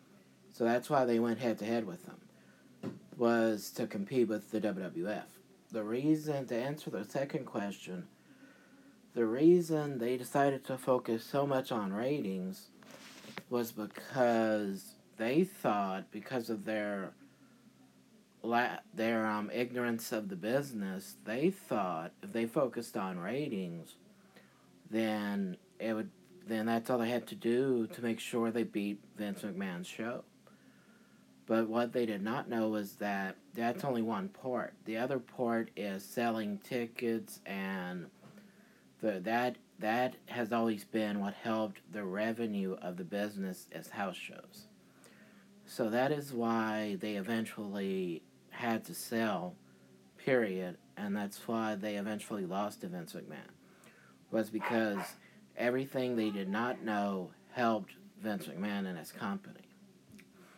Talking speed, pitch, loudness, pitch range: 135 wpm, 115 Hz, -36 LUFS, 105-125 Hz